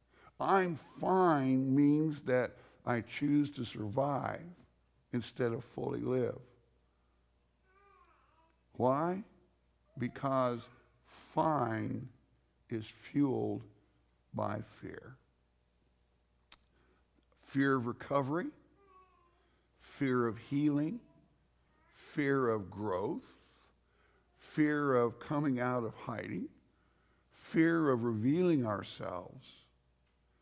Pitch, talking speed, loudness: 120 Hz, 75 wpm, -34 LUFS